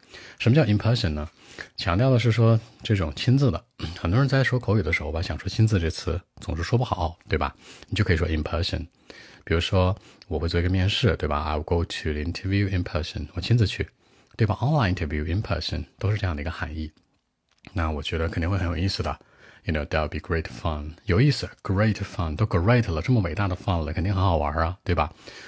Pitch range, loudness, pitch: 80-105 Hz, -25 LUFS, 90 Hz